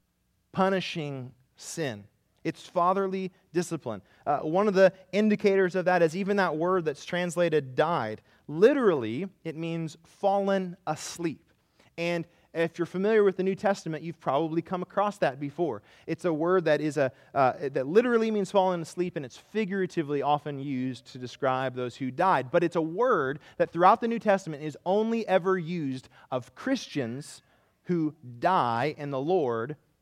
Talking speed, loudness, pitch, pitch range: 160 wpm, -28 LUFS, 170 Hz, 140-190 Hz